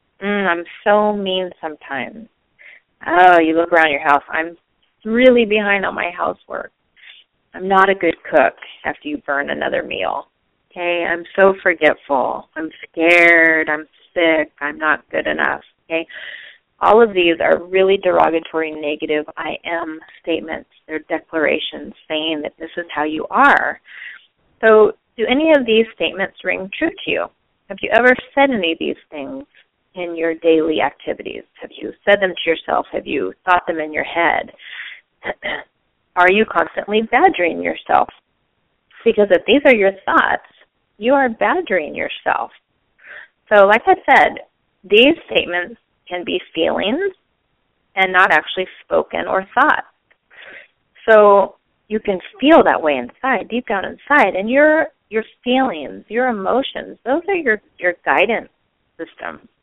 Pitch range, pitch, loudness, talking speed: 165-235 Hz, 190 Hz, -16 LUFS, 145 wpm